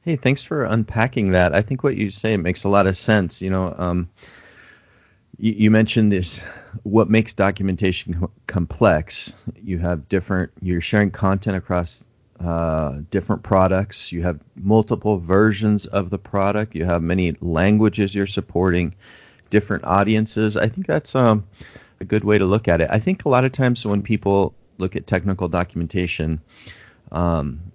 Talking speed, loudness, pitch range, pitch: 165 wpm, -20 LUFS, 90-110 Hz, 100 Hz